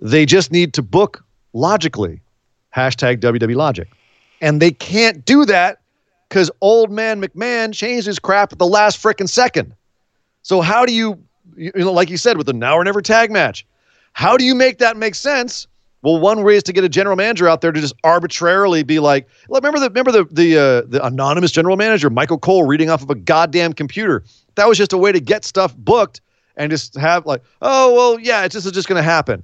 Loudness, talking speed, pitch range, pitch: -14 LUFS, 220 wpm, 150-210 Hz, 175 Hz